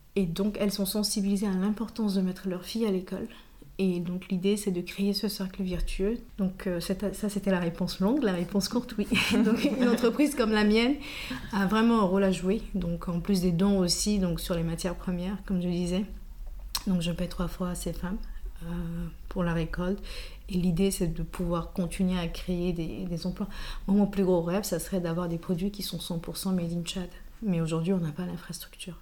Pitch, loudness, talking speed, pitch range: 190 Hz, -29 LUFS, 215 wpm, 175-200 Hz